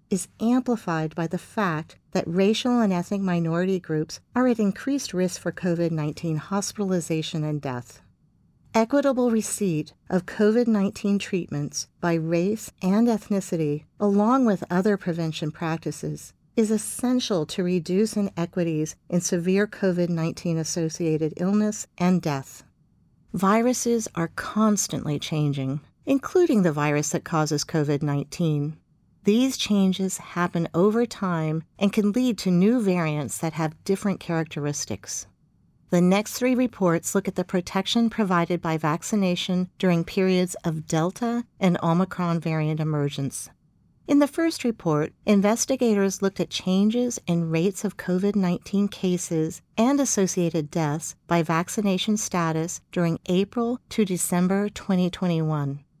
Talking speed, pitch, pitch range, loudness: 125 wpm, 180 Hz, 160-205 Hz, -24 LUFS